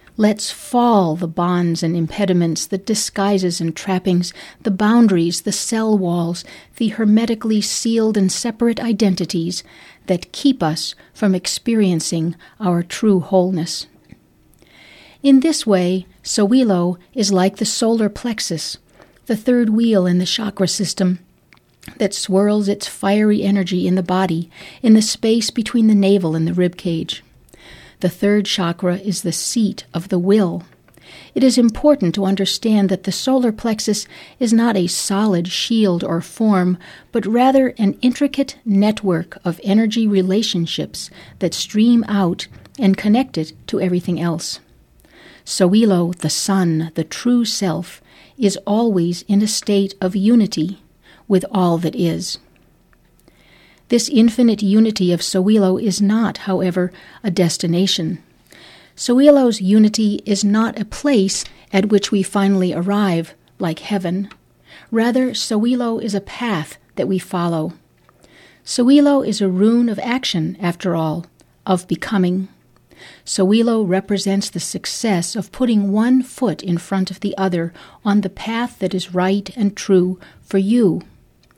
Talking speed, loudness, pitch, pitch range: 135 wpm, -17 LUFS, 195 Hz, 180-220 Hz